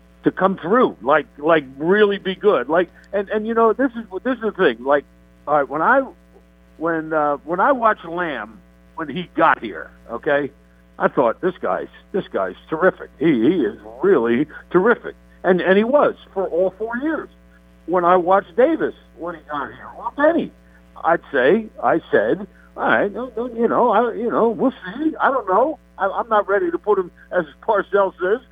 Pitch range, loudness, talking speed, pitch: 145-230 Hz, -19 LUFS, 200 wpm, 190 Hz